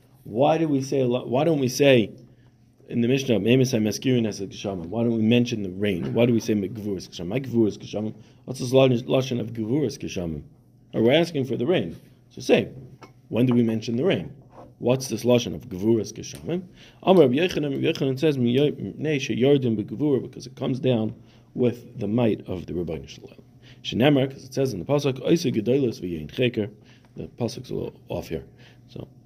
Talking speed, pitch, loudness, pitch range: 150 wpm, 125 Hz, -24 LUFS, 115-130 Hz